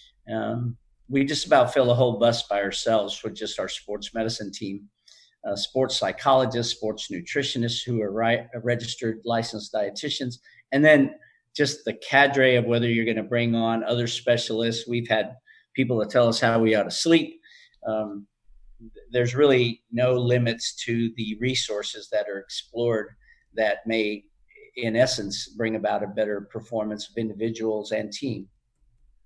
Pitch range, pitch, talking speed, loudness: 110-125 Hz, 115 Hz, 160 wpm, -24 LUFS